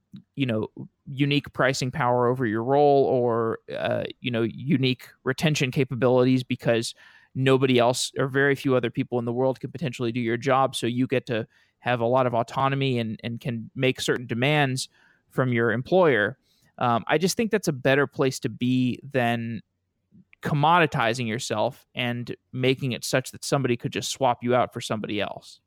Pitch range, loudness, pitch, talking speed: 120-135 Hz, -24 LUFS, 130 Hz, 180 wpm